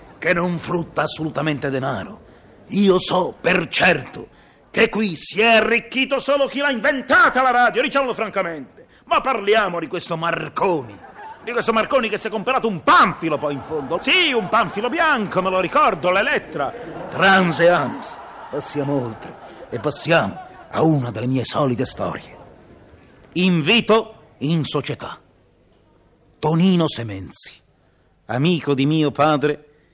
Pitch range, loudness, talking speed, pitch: 150-225 Hz, -19 LUFS, 135 wpm, 175 Hz